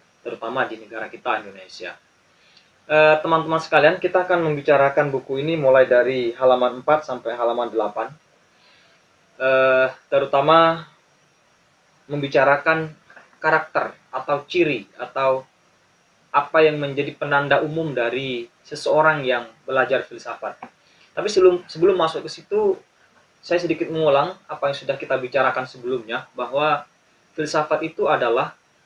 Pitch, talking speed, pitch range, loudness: 145 Hz, 110 wpm, 130-160 Hz, -20 LUFS